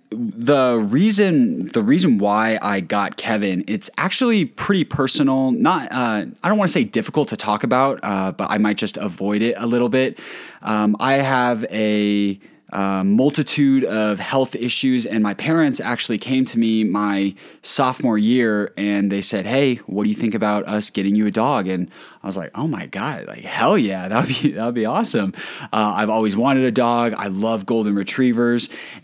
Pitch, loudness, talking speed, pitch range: 110 Hz, -19 LUFS, 190 wpm, 105-130 Hz